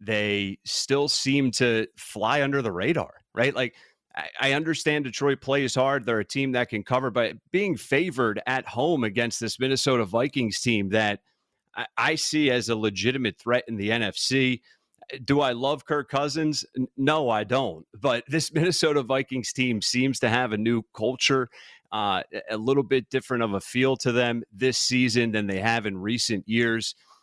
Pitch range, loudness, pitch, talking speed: 115-135 Hz, -25 LUFS, 125 Hz, 170 wpm